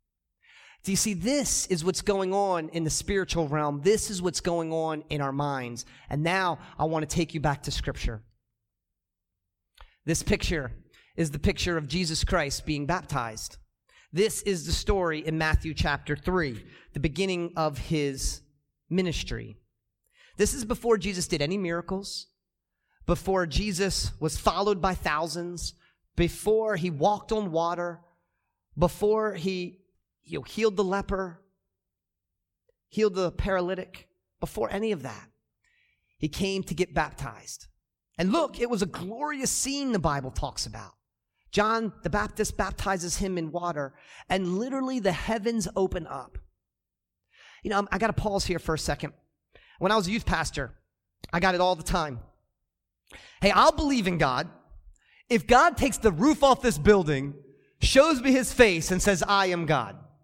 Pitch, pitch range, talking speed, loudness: 180 Hz, 150-200 Hz, 155 wpm, -27 LUFS